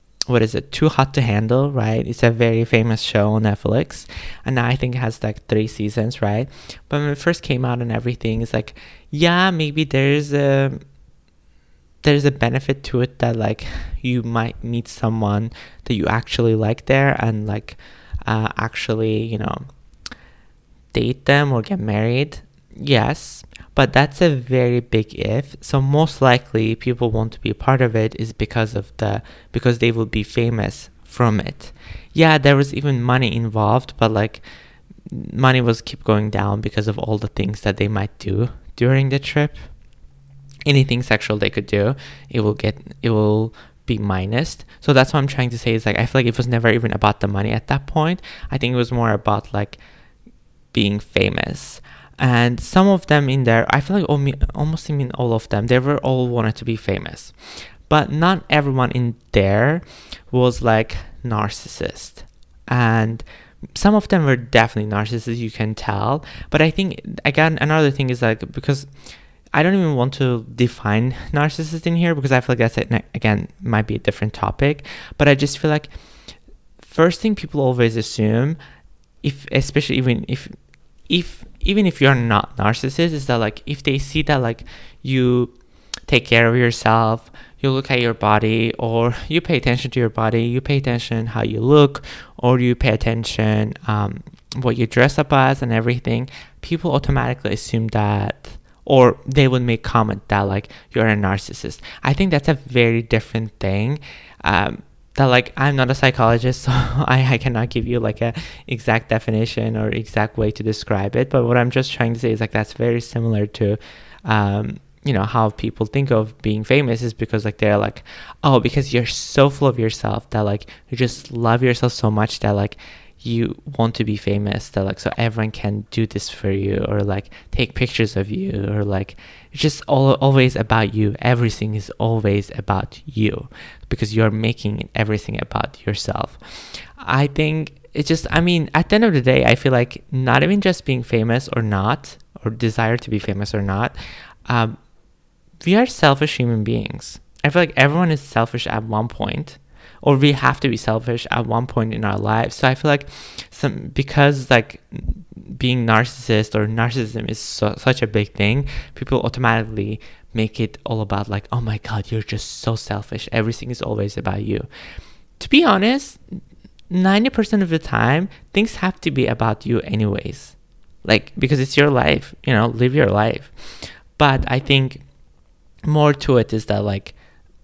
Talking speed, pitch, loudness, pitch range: 185 wpm, 120 Hz, -19 LUFS, 110-135 Hz